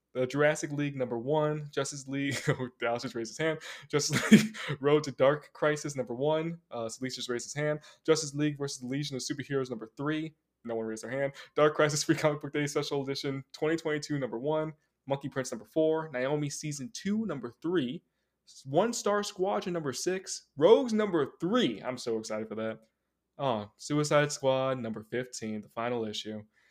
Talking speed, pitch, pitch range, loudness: 185 wpm, 145 Hz, 125-155 Hz, -31 LUFS